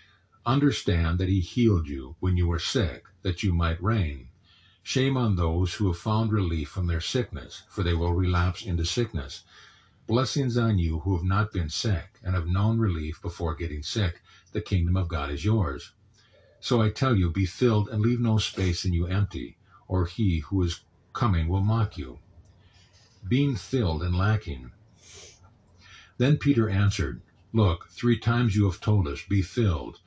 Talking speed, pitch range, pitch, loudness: 175 wpm, 85-110 Hz, 95 Hz, -26 LUFS